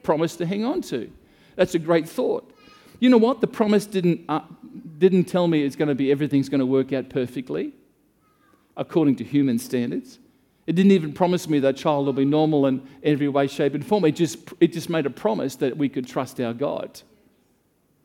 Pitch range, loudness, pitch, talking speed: 140-185 Hz, -22 LUFS, 155 Hz, 205 wpm